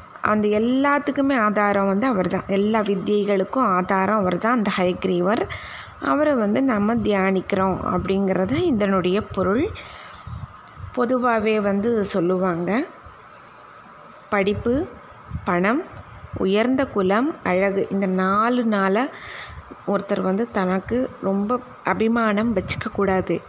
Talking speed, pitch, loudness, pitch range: 95 wpm, 205 Hz, -21 LUFS, 190-235 Hz